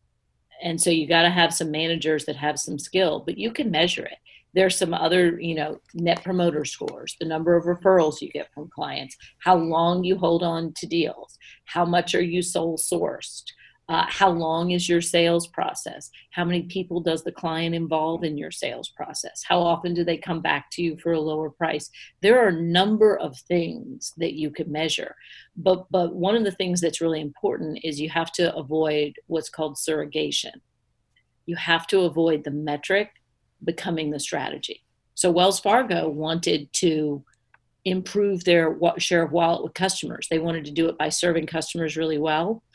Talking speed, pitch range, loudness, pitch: 190 wpm, 160-175 Hz, -23 LUFS, 165 Hz